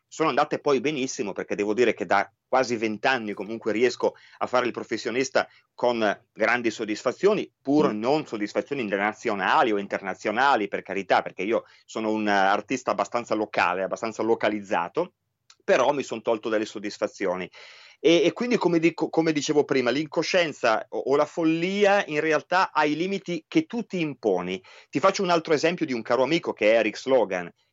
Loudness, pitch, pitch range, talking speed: -25 LUFS, 145 Hz, 110-170 Hz, 170 wpm